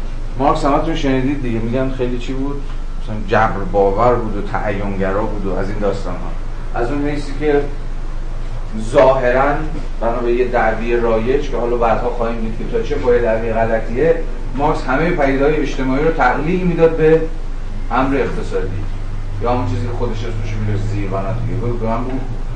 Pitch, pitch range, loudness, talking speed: 120 Hz, 110-135 Hz, -18 LUFS, 165 wpm